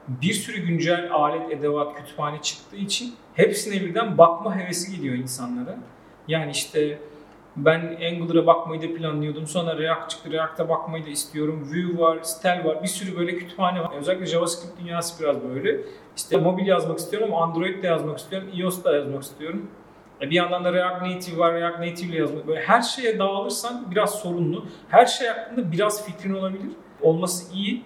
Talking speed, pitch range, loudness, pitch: 170 wpm, 160-190 Hz, -24 LUFS, 170 Hz